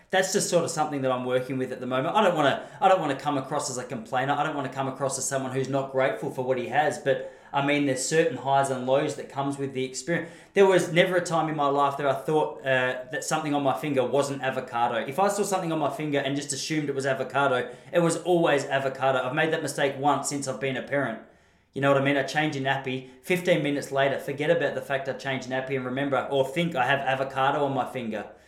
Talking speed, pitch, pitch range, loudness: 270 wpm, 140 Hz, 130-155 Hz, -26 LUFS